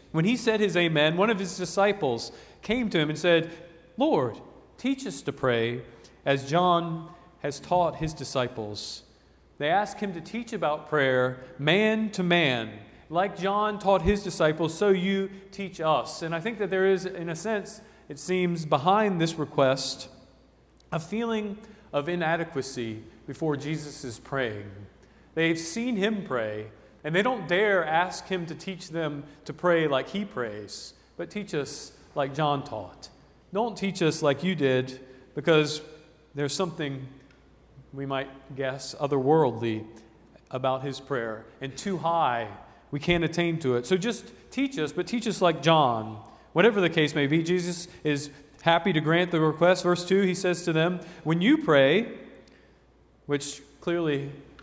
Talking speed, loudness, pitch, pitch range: 160 wpm, -27 LUFS, 160 Hz, 135-185 Hz